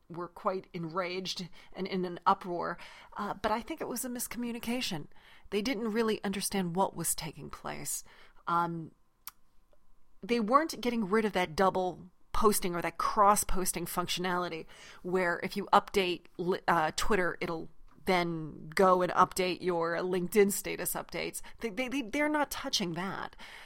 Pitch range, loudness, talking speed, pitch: 180-215 Hz, -31 LUFS, 145 wpm, 190 Hz